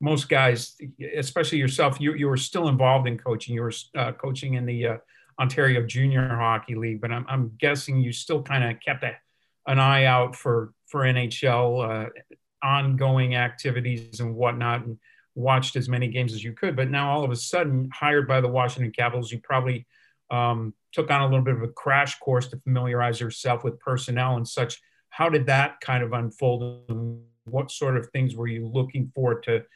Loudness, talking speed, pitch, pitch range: -24 LUFS, 195 wpm, 125 Hz, 120-135 Hz